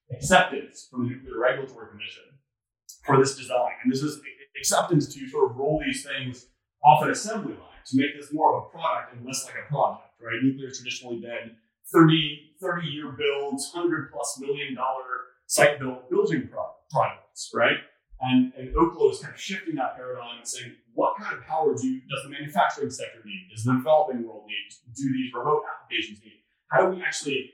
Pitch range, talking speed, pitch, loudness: 125-150 Hz, 190 wpm, 135 Hz, -26 LUFS